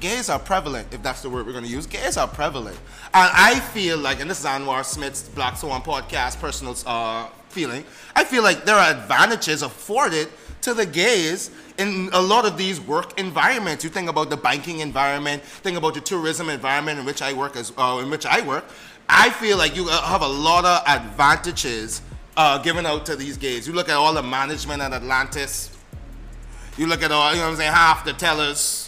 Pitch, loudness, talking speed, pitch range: 155 Hz, -20 LUFS, 210 wpm, 135-175 Hz